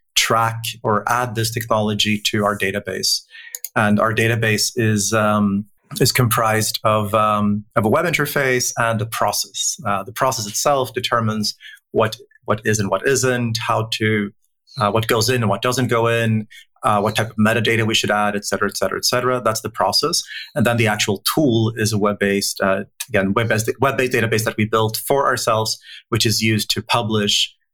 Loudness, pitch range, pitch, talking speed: -18 LUFS, 105-120 Hz, 110 Hz, 195 wpm